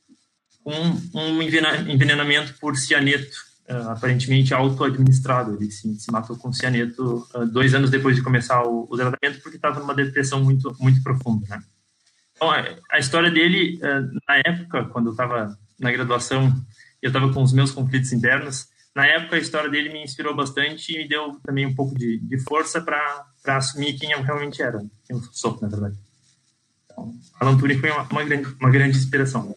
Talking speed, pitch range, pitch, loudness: 185 wpm, 125-150 Hz, 135 Hz, -21 LUFS